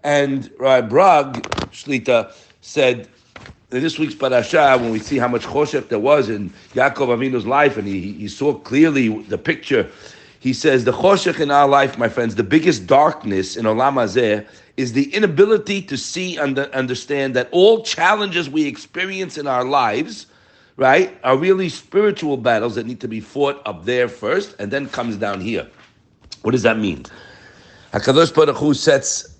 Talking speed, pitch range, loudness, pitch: 170 wpm, 120-155 Hz, -17 LUFS, 135 Hz